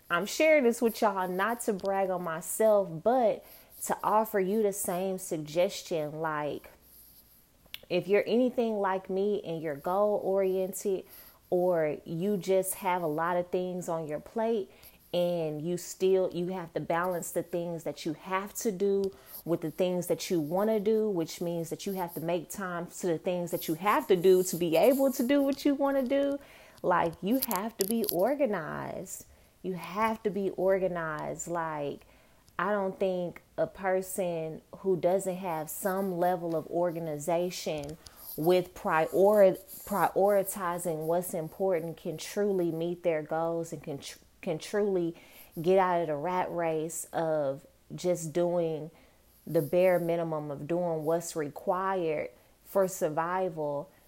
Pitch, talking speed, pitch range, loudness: 180 Hz, 160 wpm, 165-195 Hz, -30 LUFS